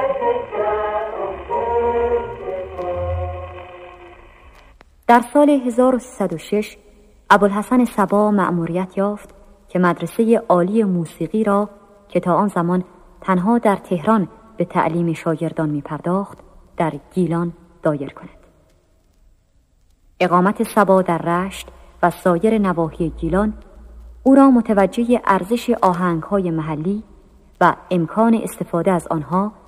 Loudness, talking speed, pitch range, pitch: -18 LUFS, 95 wpm, 170-215 Hz, 190 Hz